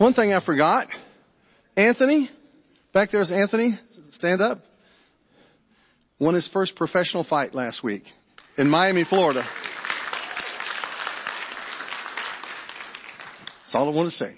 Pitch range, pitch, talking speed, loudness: 165-230 Hz, 190 Hz, 115 wpm, -23 LUFS